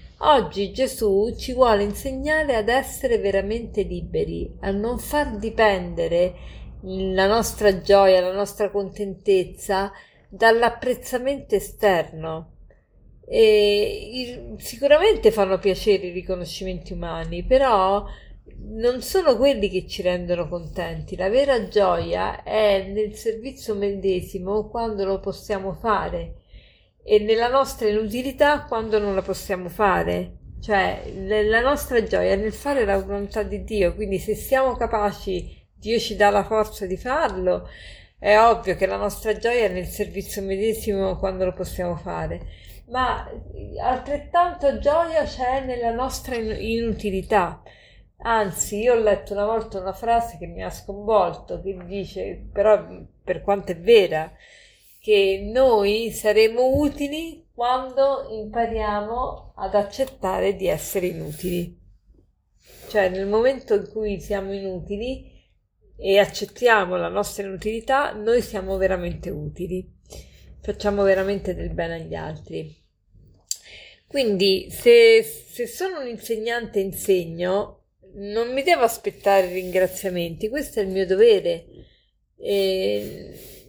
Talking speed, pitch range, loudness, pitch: 120 wpm, 190-235 Hz, -22 LUFS, 205 Hz